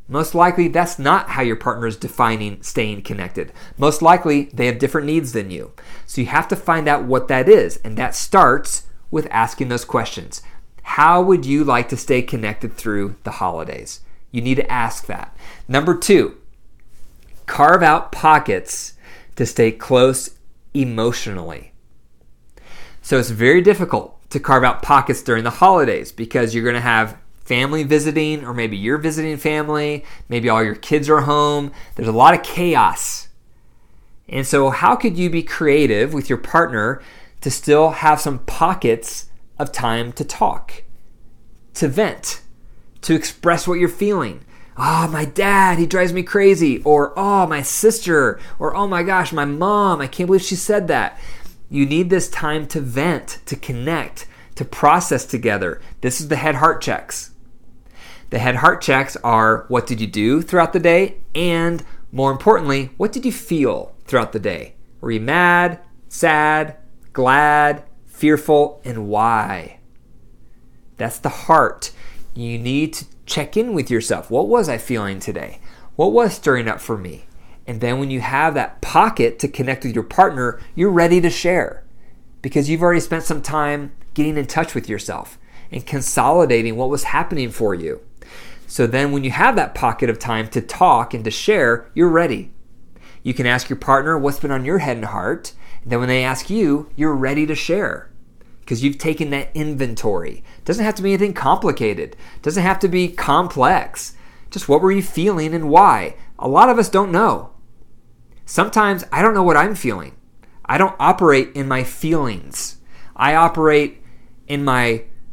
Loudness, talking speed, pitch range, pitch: -17 LUFS, 170 wpm, 120-170 Hz, 145 Hz